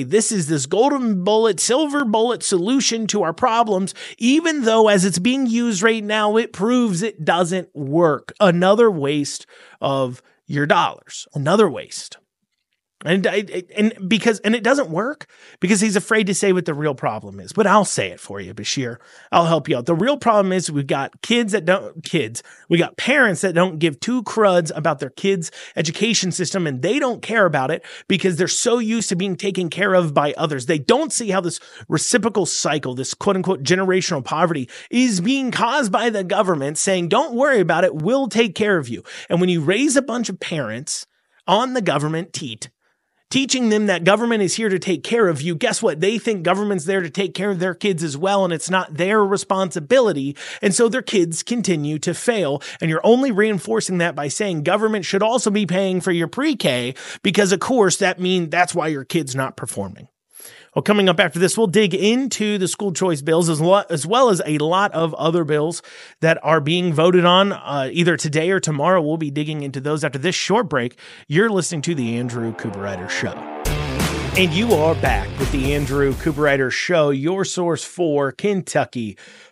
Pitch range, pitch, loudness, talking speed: 155-210 Hz, 185 Hz, -19 LUFS, 200 wpm